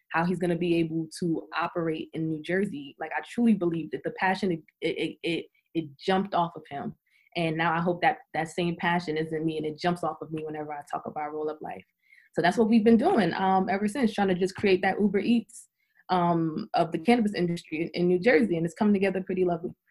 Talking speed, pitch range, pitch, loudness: 240 wpm, 165-190 Hz, 175 Hz, -27 LUFS